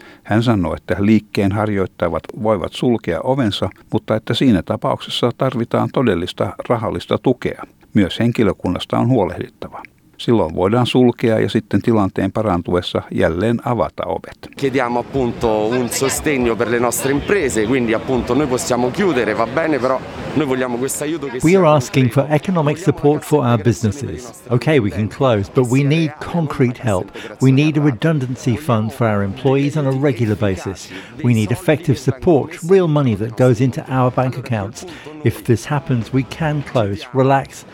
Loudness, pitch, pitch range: -17 LUFS, 125 Hz, 110-135 Hz